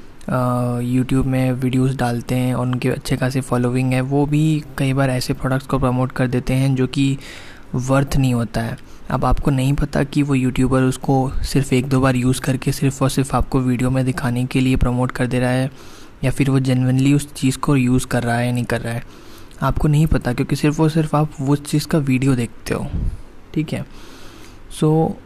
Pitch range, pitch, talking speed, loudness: 125-140 Hz, 130 Hz, 215 wpm, -19 LUFS